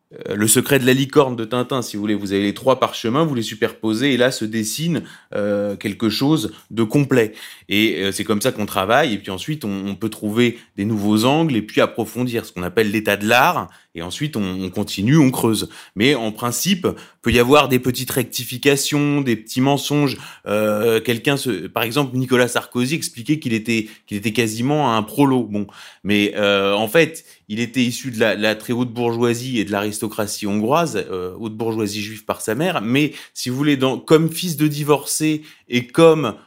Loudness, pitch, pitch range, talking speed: -19 LUFS, 120 Hz, 105-135 Hz, 205 wpm